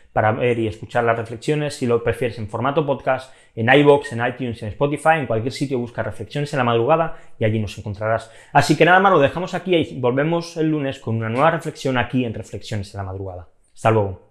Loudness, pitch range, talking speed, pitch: -20 LUFS, 110-145 Hz, 220 wpm, 125 Hz